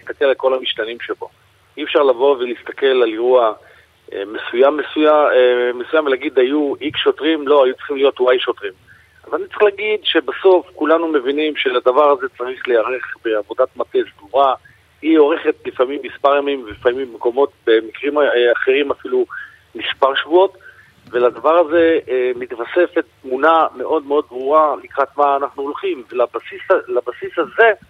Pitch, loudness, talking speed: 185 Hz, -16 LUFS, 140 wpm